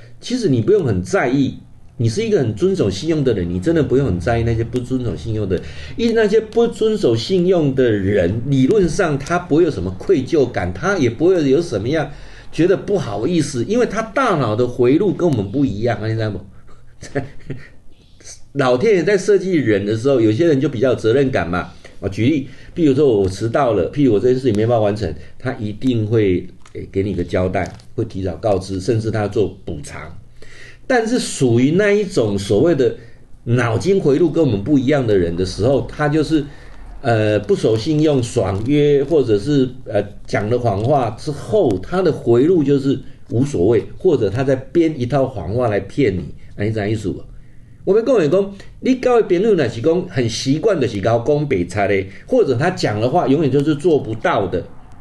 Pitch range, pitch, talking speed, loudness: 105-155 Hz, 125 Hz, 280 characters per minute, -17 LUFS